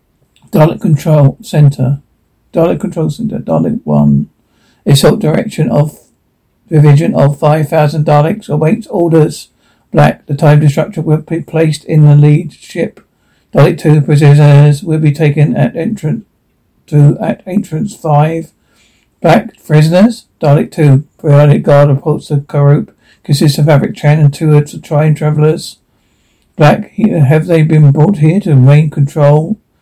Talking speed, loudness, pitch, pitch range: 135 wpm, -9 LUFS, 150 Hz, 145-160 Hz